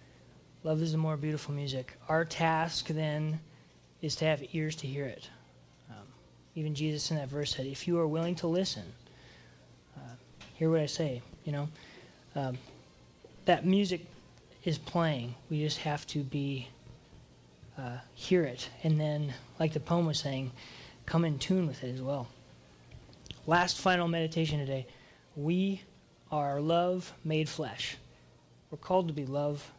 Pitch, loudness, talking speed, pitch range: 150 Hz, -33 LUFS, 155 wpm, 130-160 Hz